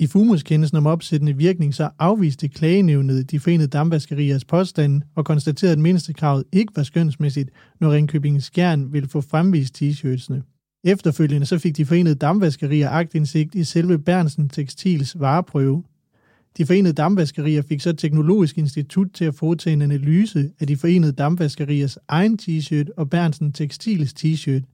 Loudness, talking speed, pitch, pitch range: -19 LUFS, 145 wpm, 155 Hz, 145-170 Hz